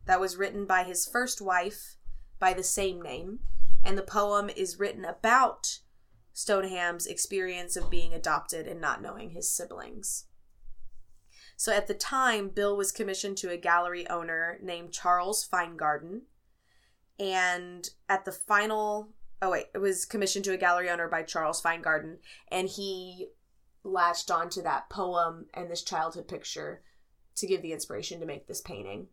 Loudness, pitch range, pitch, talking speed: -30 LUFS, 170-200 Hz, 185 Hz, 155 wpm